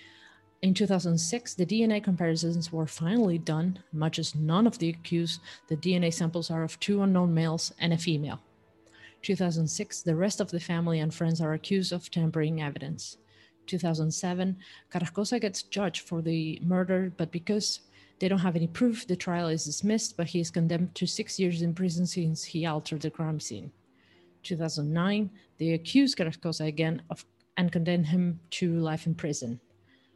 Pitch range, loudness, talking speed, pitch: 160-185 Hz, -29 LUFS, 165 wpm, 170 Hz